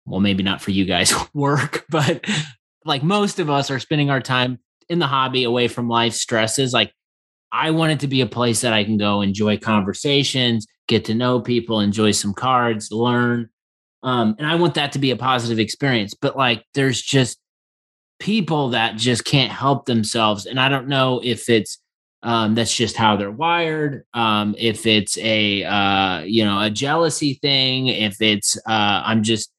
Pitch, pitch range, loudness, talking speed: 120 Hz, 110-135 Hz, -19 LUFS, 185 wpm